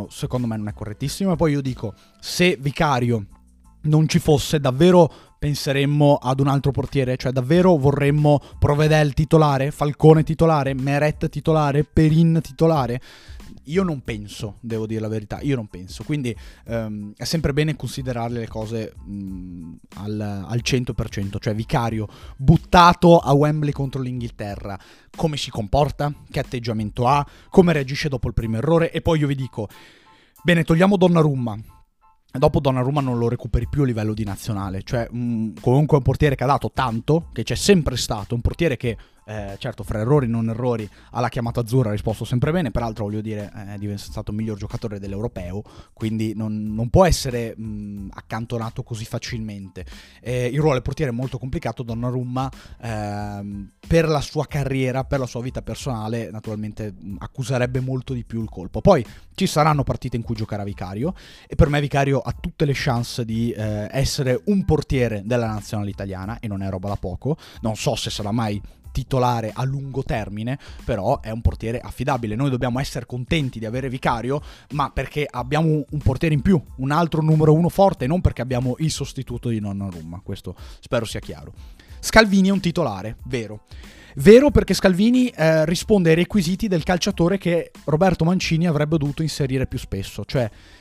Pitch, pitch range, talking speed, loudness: 125 Hz, 110-150 Hz, 175 wpm, -21 LUFS